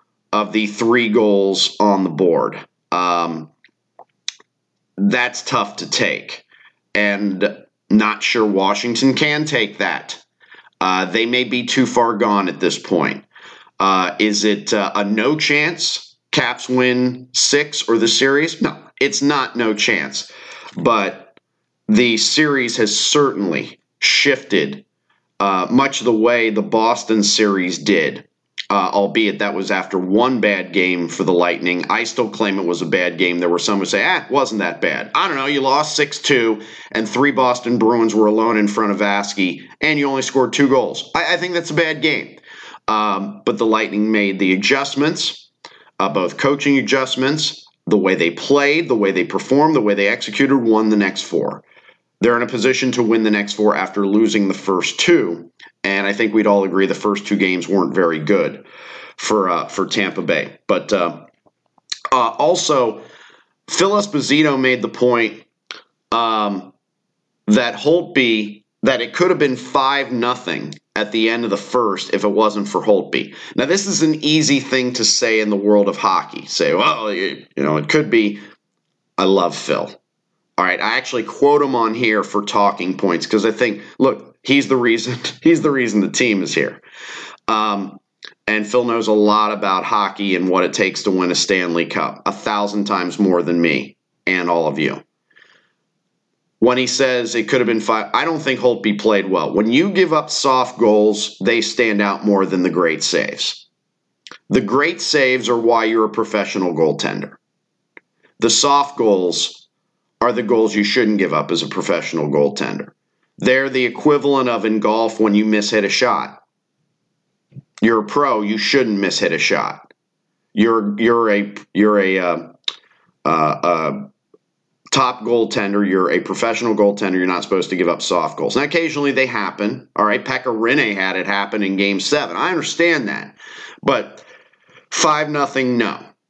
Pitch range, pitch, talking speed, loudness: 100-130 Hz, 110 Hz, 175 wpm, -17 LUFS